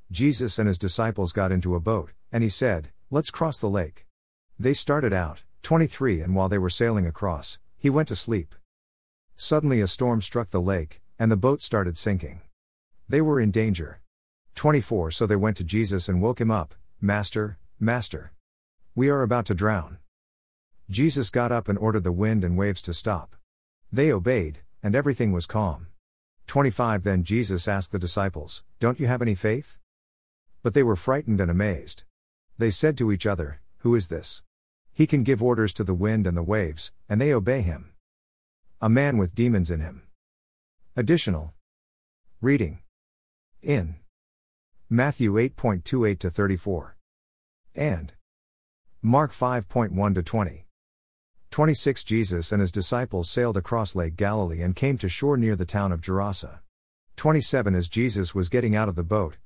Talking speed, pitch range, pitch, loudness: 165 wpm, 85-115 Hz, 100 Hz, -25 LUFS